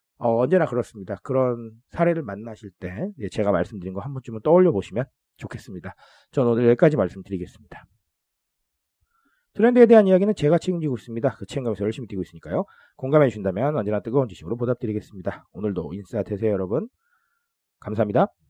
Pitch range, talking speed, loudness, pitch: 100-155 Hz, 430 characters per minute, -22 LUFS, 120 Hz